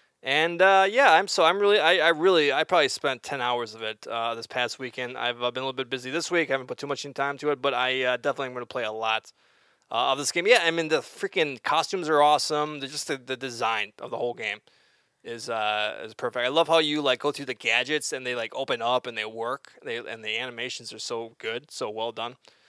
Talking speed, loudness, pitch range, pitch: 265 wpm, -25 LUFS, 120-150 Hz, 130 Hz